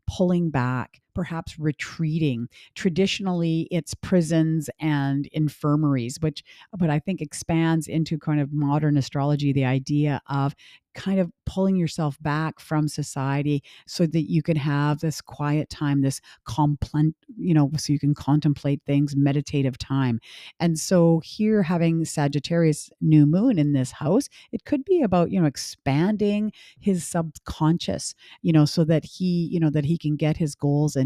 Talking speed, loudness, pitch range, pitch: 155 wpm, -24 LUFS, 145-170 Hz, 155 Hz